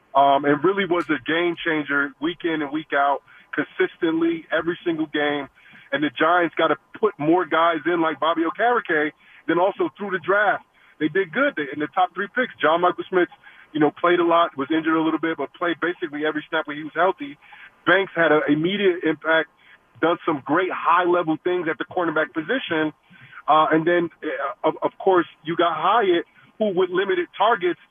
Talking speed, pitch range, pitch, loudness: 200 wpm, 155-195 Hz, 170 Hz, -22 LUFS